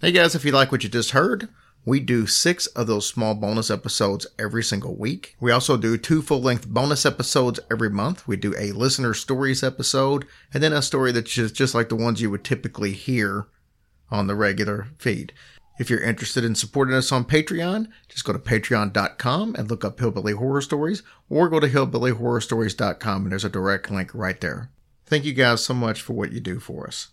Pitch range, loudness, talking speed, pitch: 105-135 Hz, -22 LUFS, 205 wpm, 120 Hz